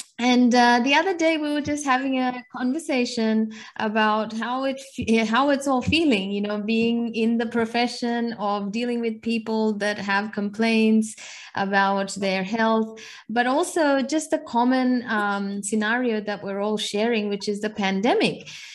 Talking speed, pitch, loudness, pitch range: 155 wpm, 230 Hz, -23 LUFS, 210-255 Hz